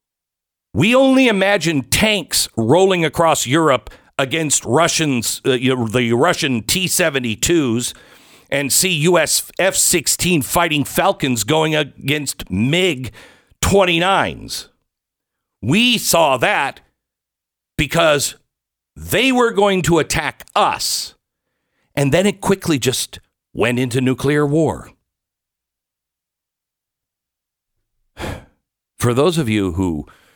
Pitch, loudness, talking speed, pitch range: 155 Hz, -16 LUFS, 95 wpm, 125-180 Hz